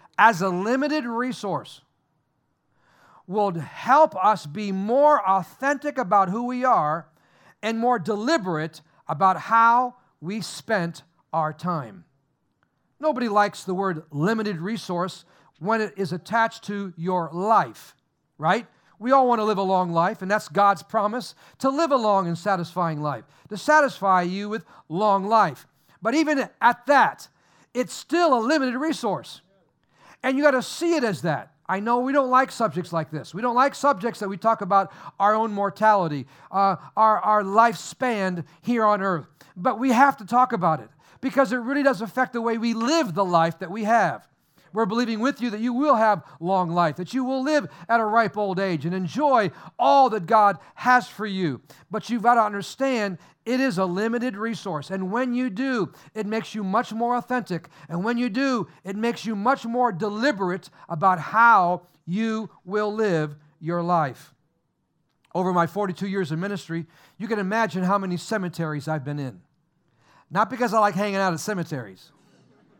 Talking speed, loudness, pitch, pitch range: 175 wpm, -23 LUFS, 205 Hz, 175-240 Hz